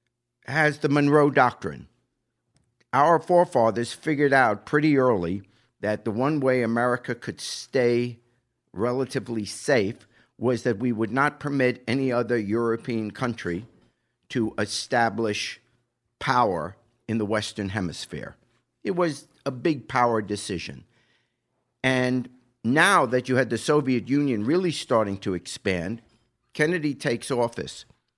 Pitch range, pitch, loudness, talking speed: 115-135 Hz, 120 Hz, -24 LUFS, 120 wpm